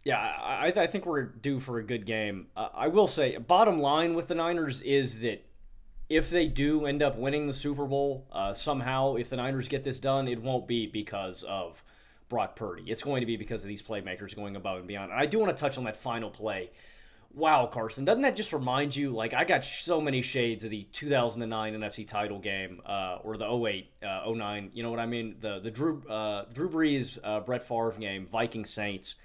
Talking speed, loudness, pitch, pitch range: 225 wpm, -31 LUFS, 115 Hz, 110-140 Hz